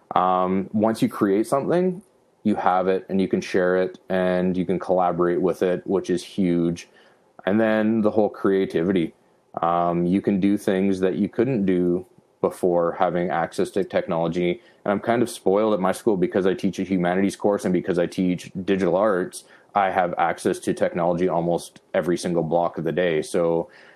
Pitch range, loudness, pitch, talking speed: 90-100 Hz, -23 LUFS, 95 Hz, 185 wpm